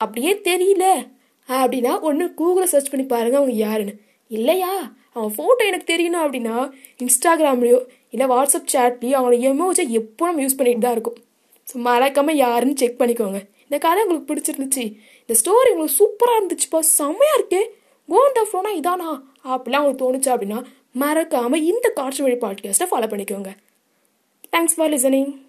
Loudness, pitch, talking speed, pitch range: -18 LUFS, 275 Hz, 140 wpm, 245-340 Hz